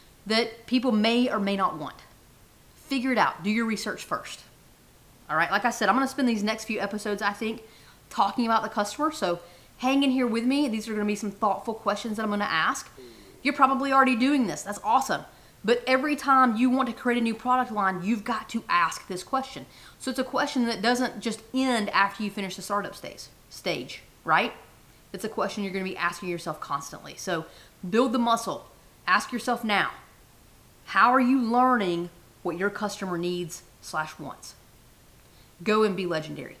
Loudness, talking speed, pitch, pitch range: -26 LUFS, 195 wpm, 220 Hz, 195-255 Hz